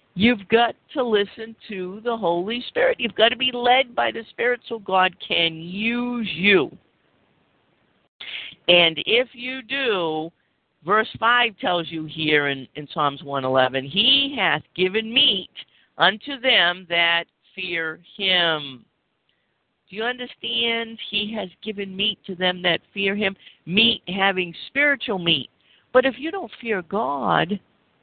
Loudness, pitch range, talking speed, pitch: -21 LUFS, 170-235 Hz, 140 wpm, 200 Hz